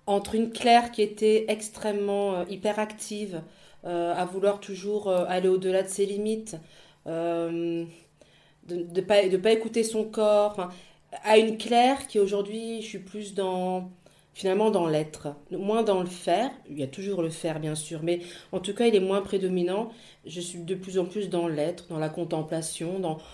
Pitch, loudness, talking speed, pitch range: 190 Hz, -27 LUFS, 185 wpm, 175-210 Hz